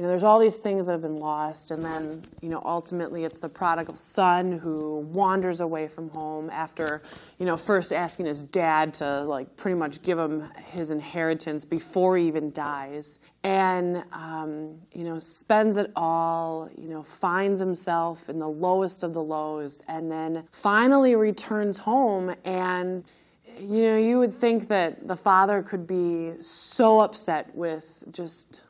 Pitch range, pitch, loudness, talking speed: 160-190 Hz, 170 Hz, -26 LUFS, 165 wpm